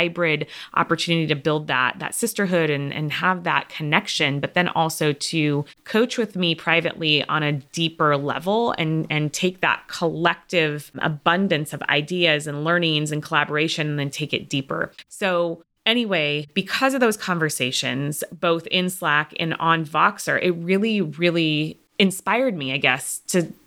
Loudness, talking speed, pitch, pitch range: -22 LUFS, 155 wpm, 165 Hz, 150-180 Hz